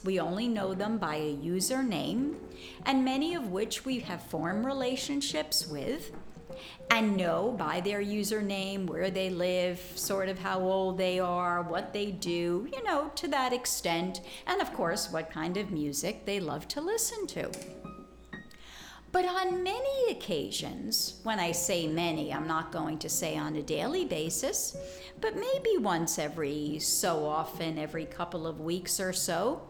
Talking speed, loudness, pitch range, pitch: 160 wpm, -31 LUFS, 165-240 Hz, 185 Hz